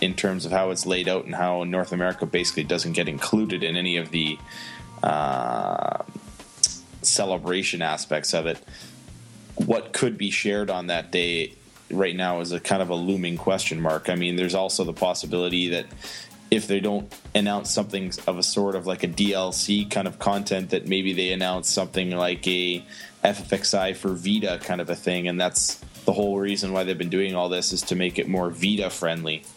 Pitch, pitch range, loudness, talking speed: 90 Hz, 90-95 Hz, -24 LUFS, 195 wpm